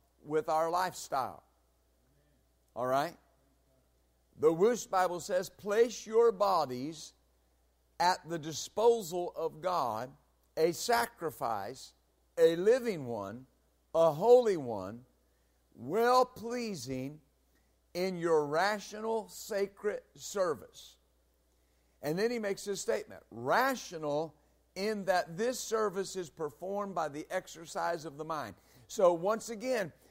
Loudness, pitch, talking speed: -32 LUFS, 170 Hz, 110 wpm